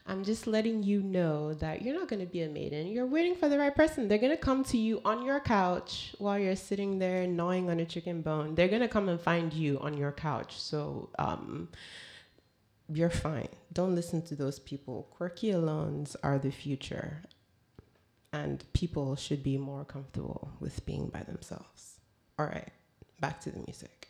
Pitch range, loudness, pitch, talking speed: 150-210 Hz, -33 LUFS, 175 Hz, 185 wpm